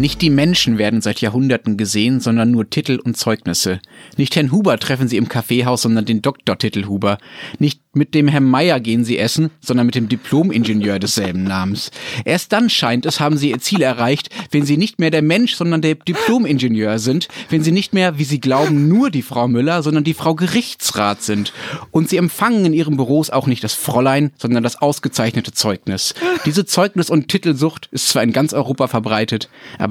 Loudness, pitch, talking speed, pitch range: -16 LUFS, 135 Hz, 195 wpm, 115-160 Hz